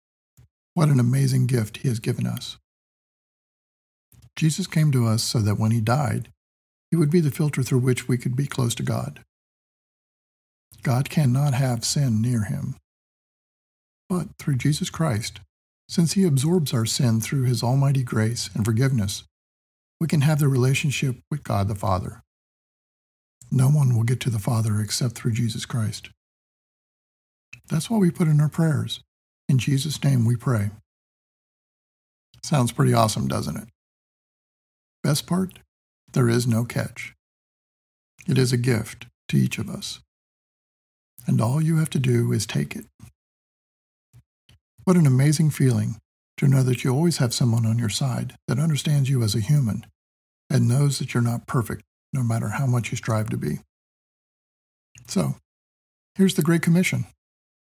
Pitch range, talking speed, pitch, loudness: 105-140 Hz, 155 wpm, 120 Hz, -23 LUFS